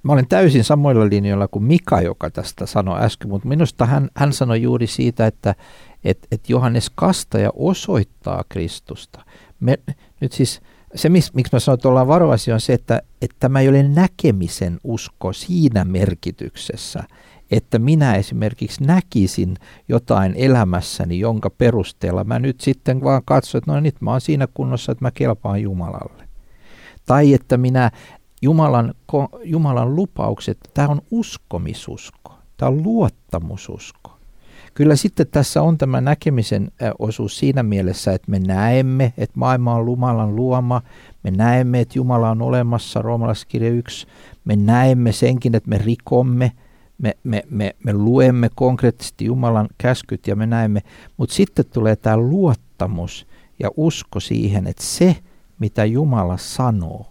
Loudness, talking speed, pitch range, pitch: -18 LUFS, 145 wpm, 105-135 Hz, 120 Hz